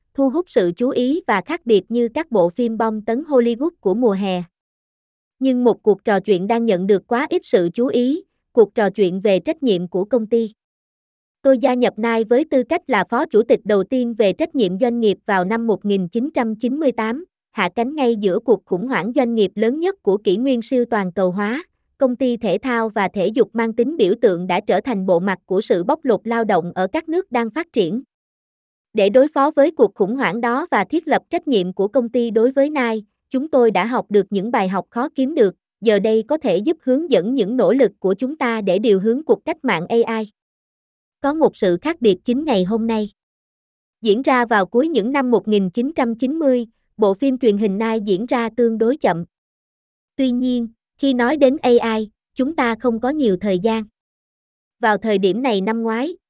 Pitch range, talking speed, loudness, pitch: 205-265 Hz, 215 wpm, -18 LUFS, 235 Hz